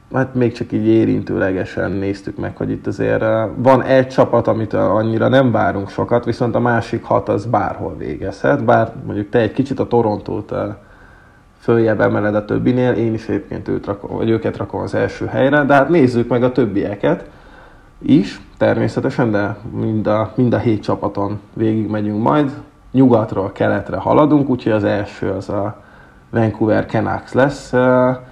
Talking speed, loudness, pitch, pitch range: 155 wpm, -17 LUFS, 115 Hz, 105-125 Hz